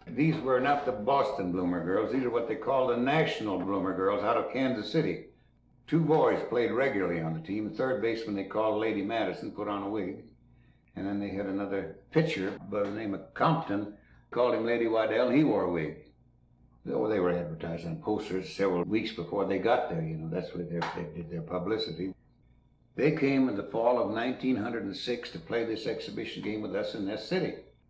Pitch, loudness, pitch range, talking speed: 105 Hz, -30 LUFS, 95-125 Hz, 200 wpm